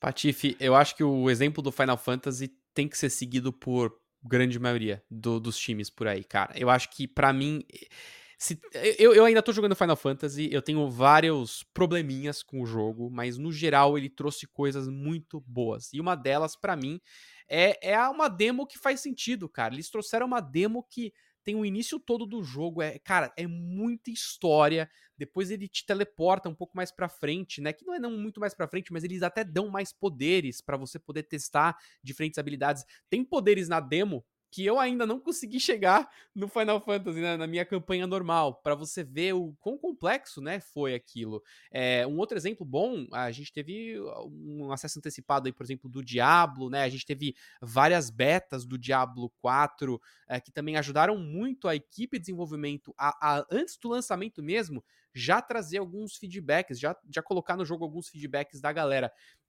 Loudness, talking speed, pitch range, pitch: -28 LUFS, 190 wpm, 135-195 Hz, 155 Hz